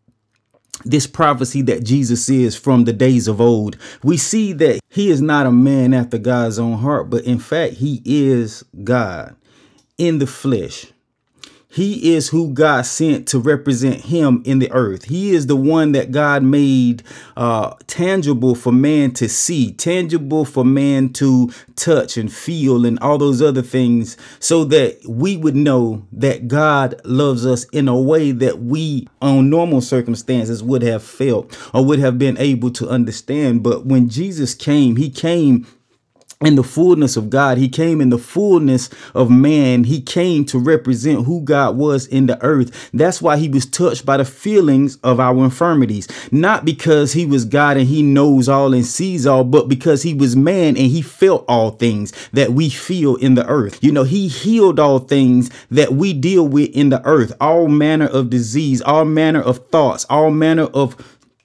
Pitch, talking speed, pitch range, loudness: 135 Hz, 180 wpm, 125-150 Hz, -15 LUFS